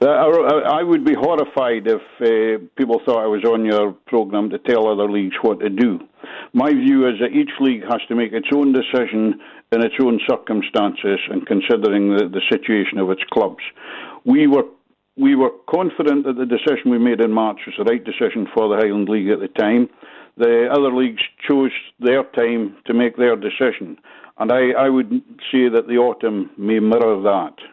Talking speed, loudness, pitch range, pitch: 190 wpm, -18 LUFS, 110-140 Hz, 120 Hz